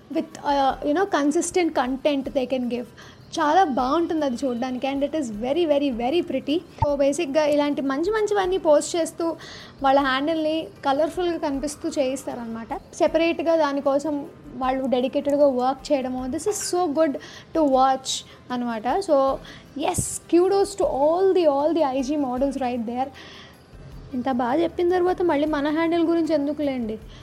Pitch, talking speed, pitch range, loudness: 295 Hz, 140 wpm, 270-325 Hz, -23 LUFS